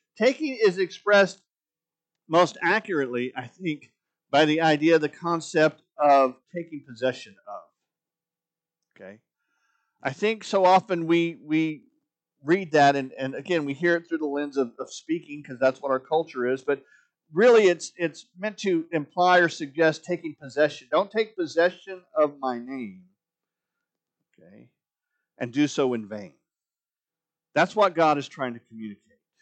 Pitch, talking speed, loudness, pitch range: 165 Hz, 150 wpm, -24 LUFS, 140-180 Hz